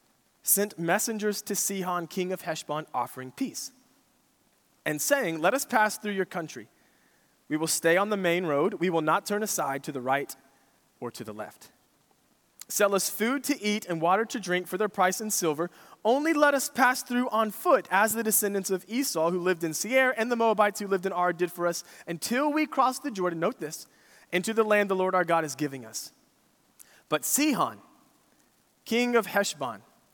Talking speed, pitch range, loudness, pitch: 195 wpm, 175-235 Hz, -27 LUFS, 200 Hz